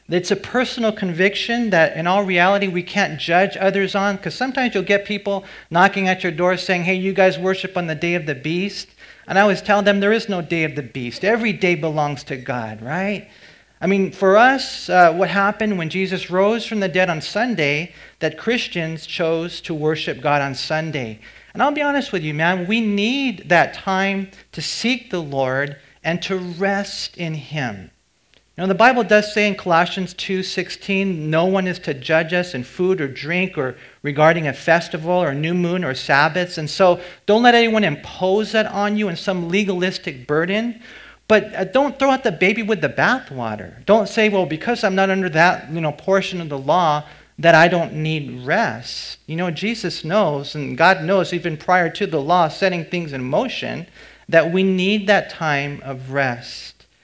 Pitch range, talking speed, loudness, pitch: 160-200 Hz, 195 wpm, -19 LUFS, 185 Hz